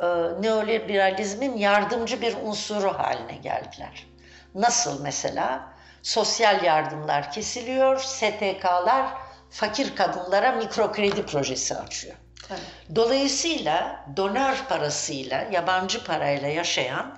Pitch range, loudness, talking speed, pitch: 170-235 Hz, -24 LUFS, 80 wpm, 205 Hz